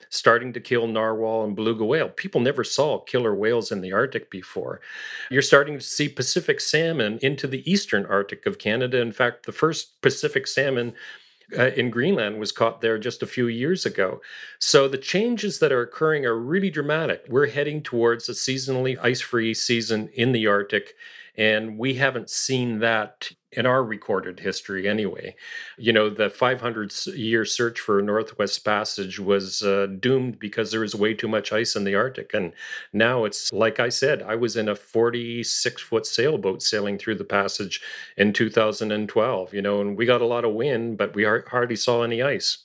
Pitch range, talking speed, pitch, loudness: 110-130 Hz, 185 wpm, 115 Hz, -23 LUFS